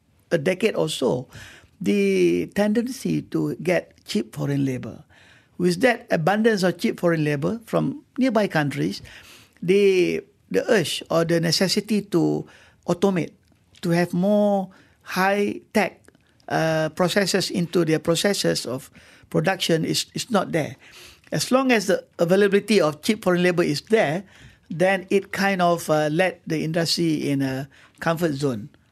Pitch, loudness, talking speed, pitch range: 175 Hz, -22 LUFS, 140 wpm, 155-200 Hz